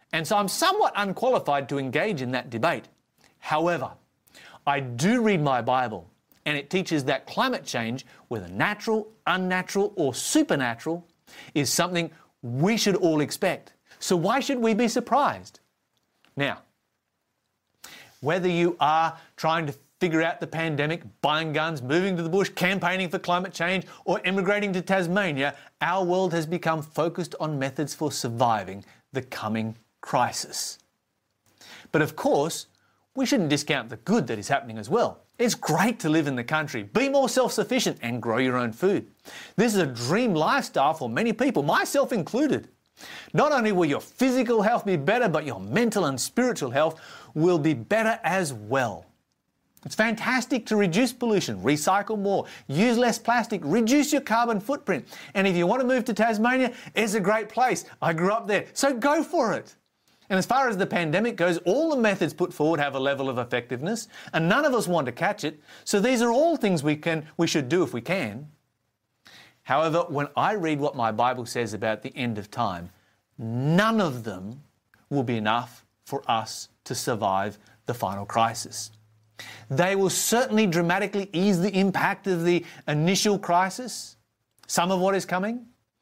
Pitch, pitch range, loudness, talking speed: 175 Hz, 135-210 Hz, -25 LUFS, 170 wpm